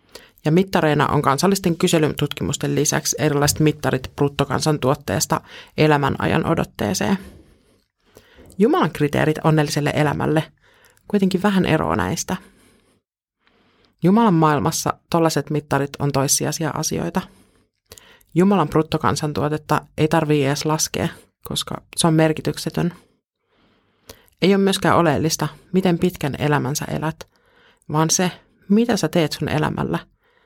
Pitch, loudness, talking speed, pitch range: 155 Hz, -20 LUFS, 100 wpm, 145-175 Hz